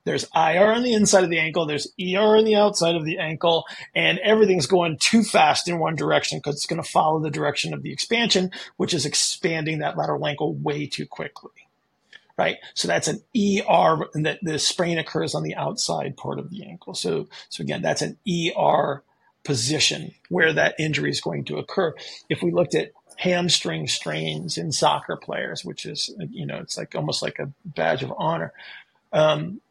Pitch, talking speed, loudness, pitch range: 170 Hz, 190 wpm, -22 LUFS, 155-190 Hz